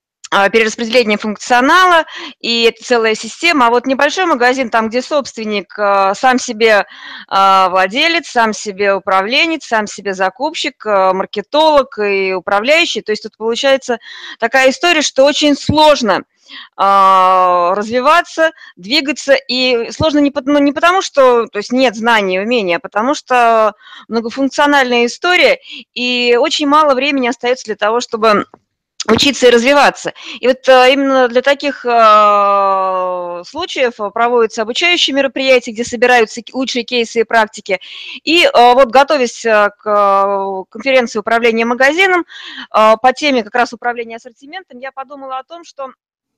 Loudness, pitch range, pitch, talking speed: -12 LUFS, 215-275 Hz, 245 Hz, 125 wpm